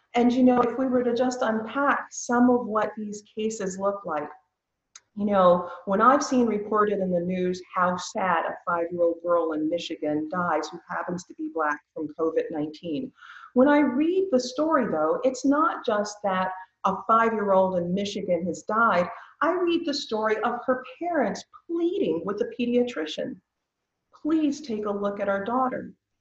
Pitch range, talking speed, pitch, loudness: 180-255 Hz, 170 wpm, 210 Hz, -25 LUFS